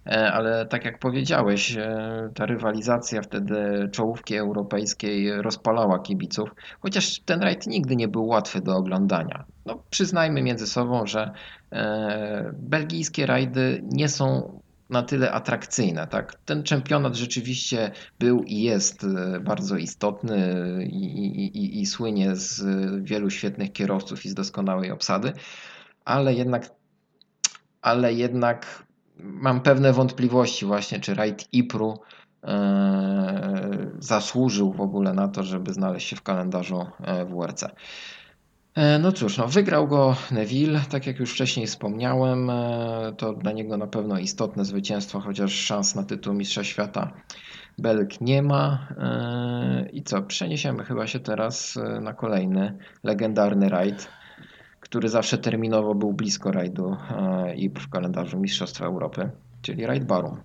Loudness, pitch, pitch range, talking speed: -25 LUFS, 110 Hz, 100-130 Hz, 125 wpm